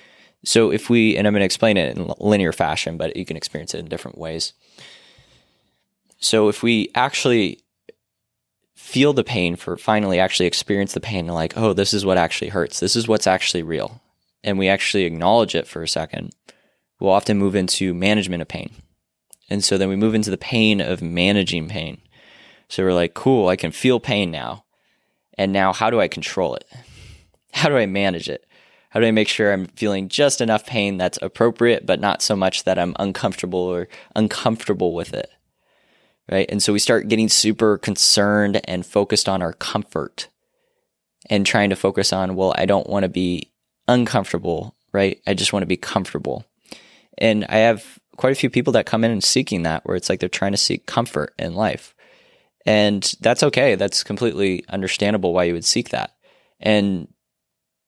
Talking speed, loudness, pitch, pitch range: 190 wpm, -19 LUFS, 100 Hz, 95-110 Hz